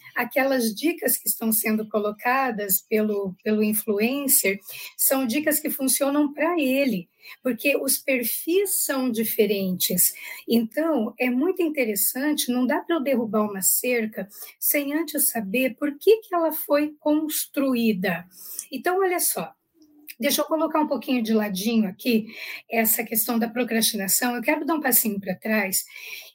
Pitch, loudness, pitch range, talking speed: 255 Hz, -23 LUFS, 220-295 Hz, 140 wpm